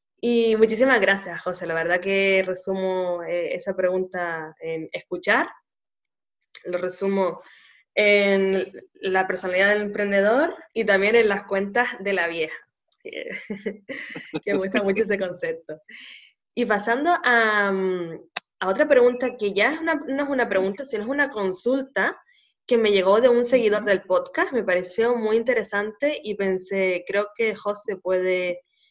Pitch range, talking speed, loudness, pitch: 185-240 Hz, 145 wpm, -22 LUFS, 205 Hz